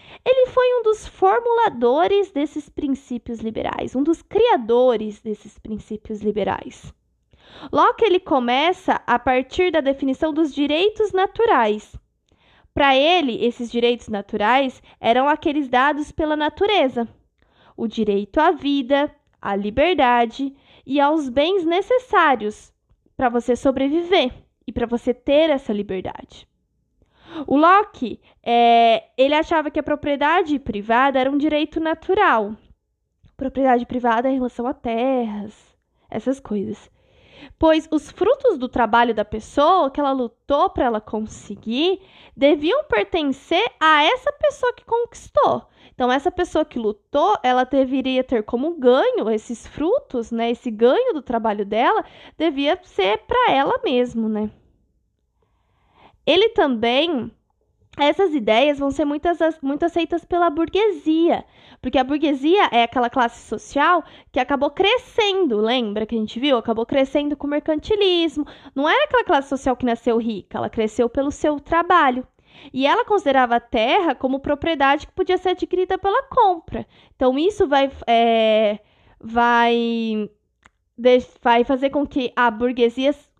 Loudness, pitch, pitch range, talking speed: -19 LUFS, 275 Hz, 235-330 Hz, 135 wpm